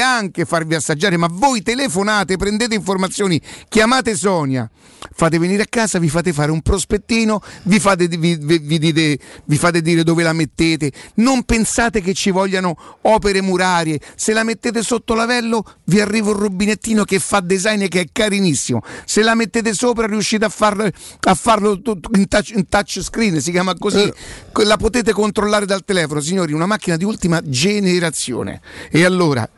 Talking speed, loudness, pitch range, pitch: 165 wpm, -16 LUFS, 170-220 Hz, 195 Hz